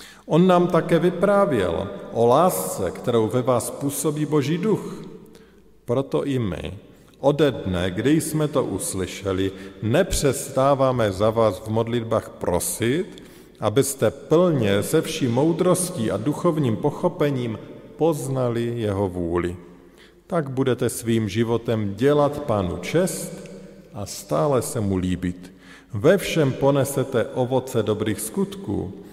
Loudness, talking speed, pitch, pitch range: -22 LUFS, 115 wpm, 125 Hz, 105-155 Hz